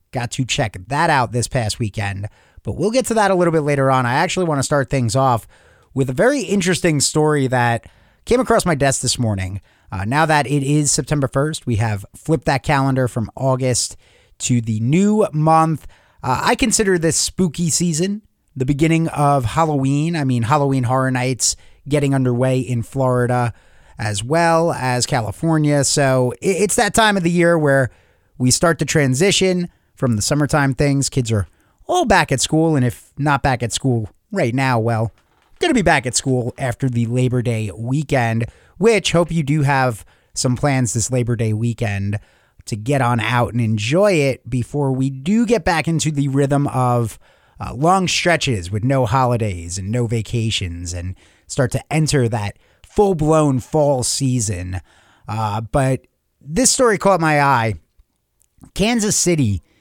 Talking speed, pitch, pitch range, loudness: 175 wpm, 135 Hz, 115-155 Hz, -18 LUFS